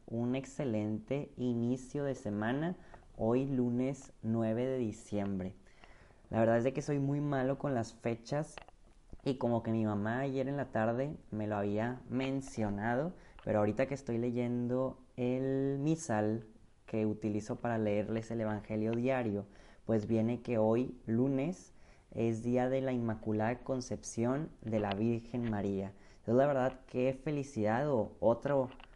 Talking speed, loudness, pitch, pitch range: 145 wpm, -35 LUFS, 120 Hz, 110-130 Hz